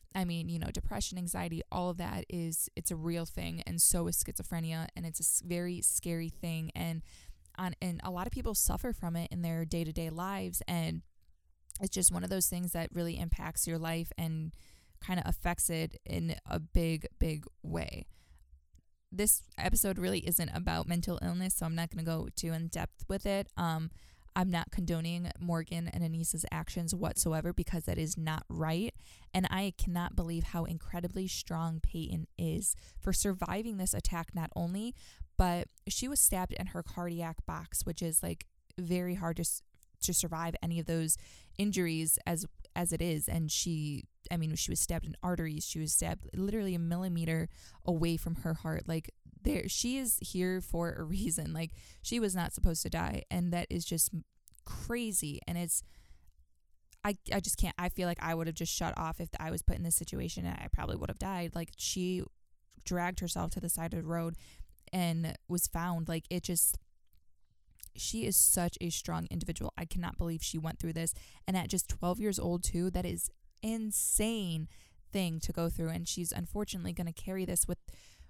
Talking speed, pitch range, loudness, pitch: 190 wpm, 155-180 Hz, -34 LUFS, 170 Hz